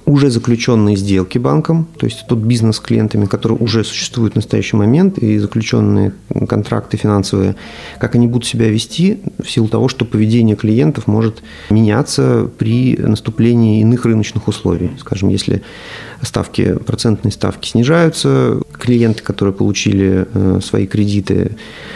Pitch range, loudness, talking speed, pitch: 105-125 Hz, -14 LUFS, 135 wpm, 115 Hz